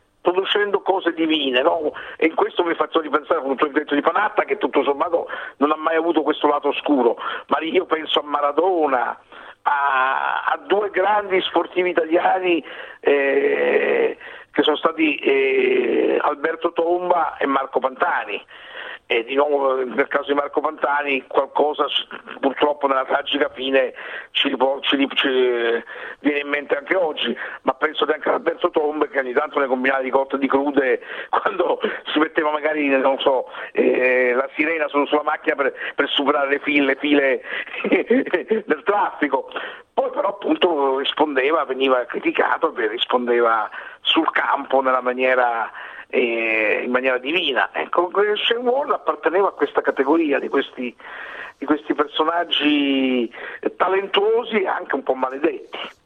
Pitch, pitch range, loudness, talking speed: 150 Hz, 135-185 Hz, -20 LUFS, 145 wpm